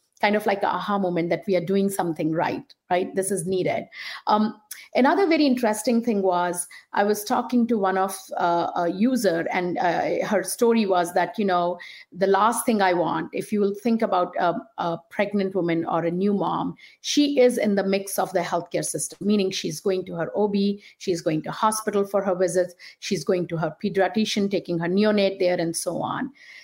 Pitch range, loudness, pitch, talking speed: 175-210 Hz, -23 LUFS, 190 Hz, 205 wpm